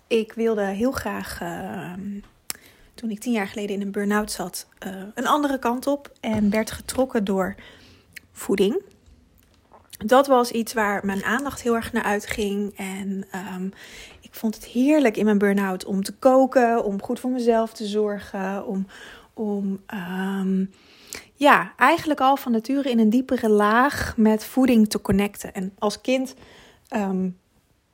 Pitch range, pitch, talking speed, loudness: 195-245 Hz, 215 Hz, 155 wpm, -23 LUFS